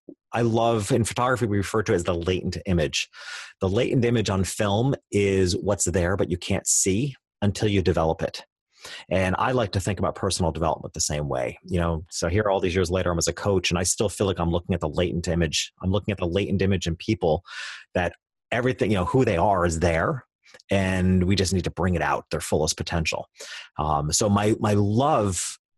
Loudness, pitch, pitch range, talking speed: -24 LUFS, 95 Hz, 85-105 Hz, 220 wpm